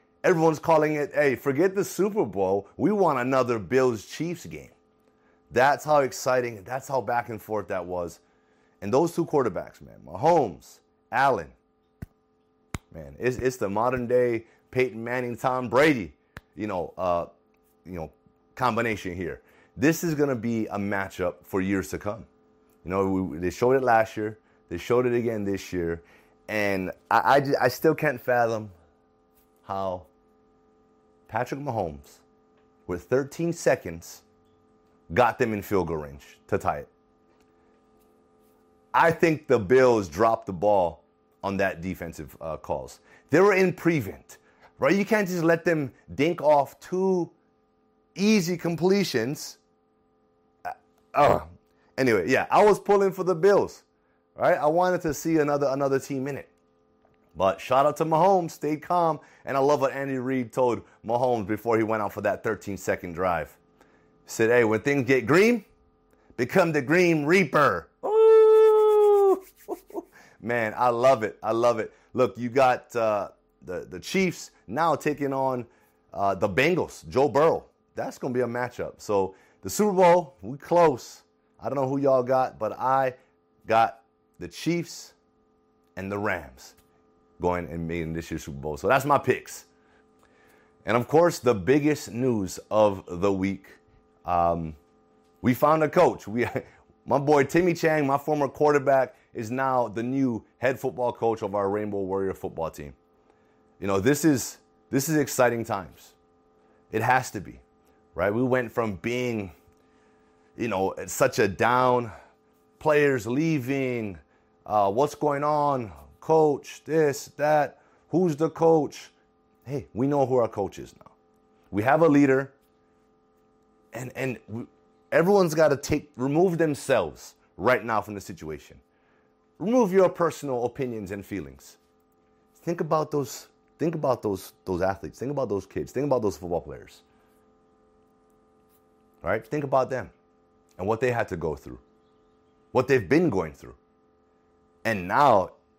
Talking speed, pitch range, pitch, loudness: 150 wpm, 85-140 Hz, 110 Hz, -25 LUFS